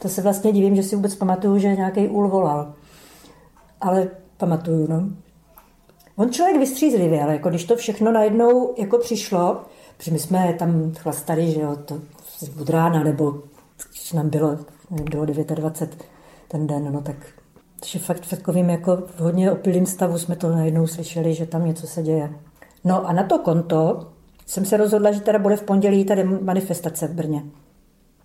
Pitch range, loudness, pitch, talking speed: 160-195 Hz, -21 LUFS, 175 Hz, 175 wpm